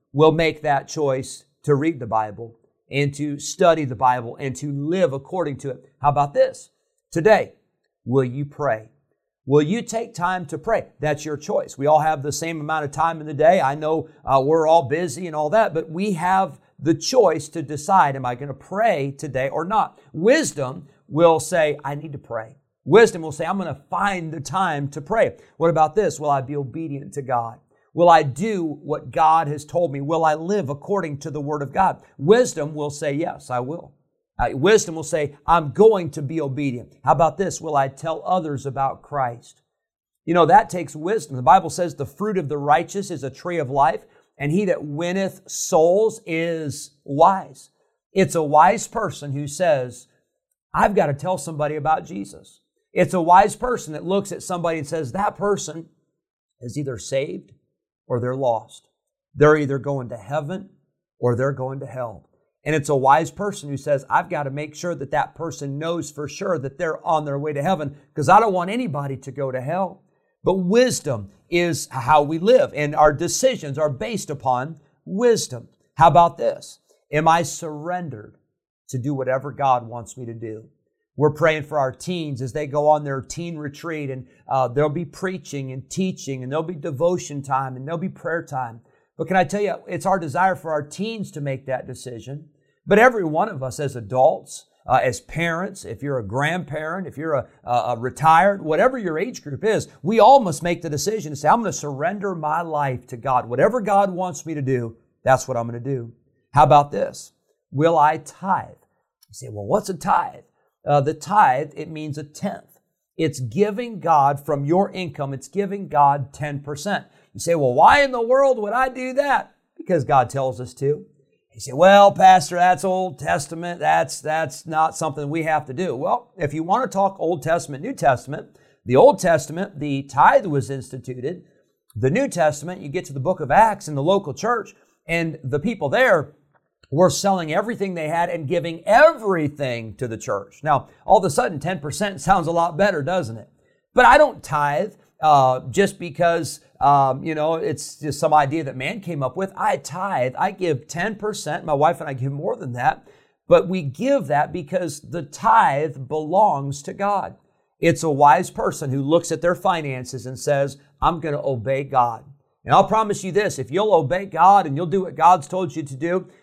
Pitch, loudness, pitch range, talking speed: 155 Hz, -20 LUFS, 140-180 Hz, 200 wpm